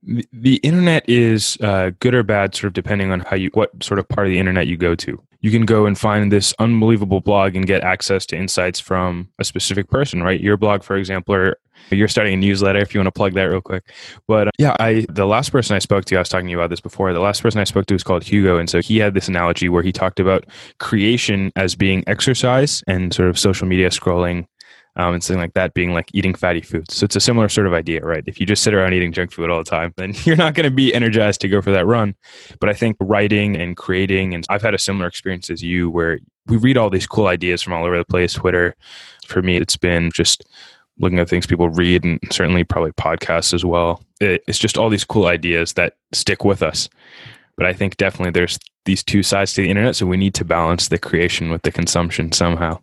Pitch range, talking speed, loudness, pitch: 90-105 Hz, 250 wpm, -17 LUFS, 95 Hz